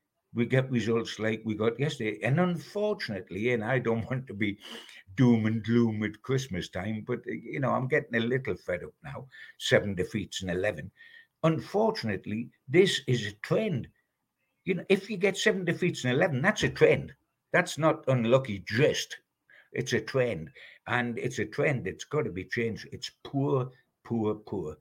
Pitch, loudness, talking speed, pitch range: 125 Hz, -29 LUFS, 175 wpm, 110-155 Hz